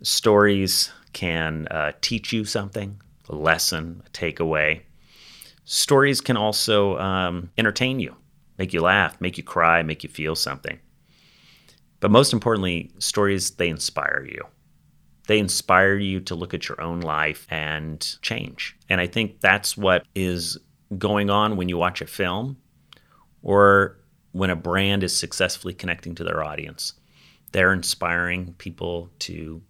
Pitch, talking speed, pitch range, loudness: 90 Hz, 145 wpm, 85-100 Hz, -22 LUFS